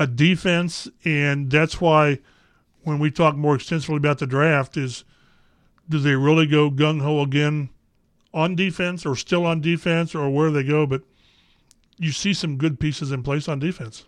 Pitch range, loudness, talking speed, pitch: 140-160 Hz, -21 LUFS, 180 wpm, 150 Hz